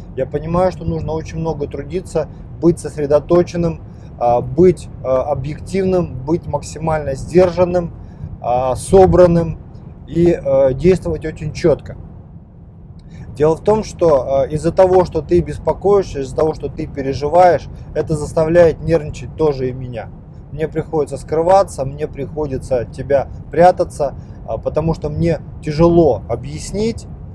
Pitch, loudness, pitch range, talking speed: 155 Hz, -16 LUFS, 135-170 Hz, 115 wpm